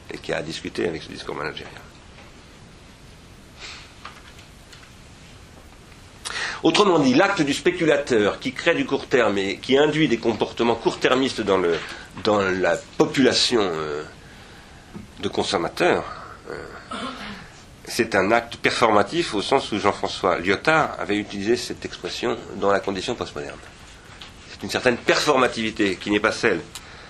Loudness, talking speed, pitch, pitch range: -22 LUFS, 130 wpm, 115 Hz, 100-150 Hz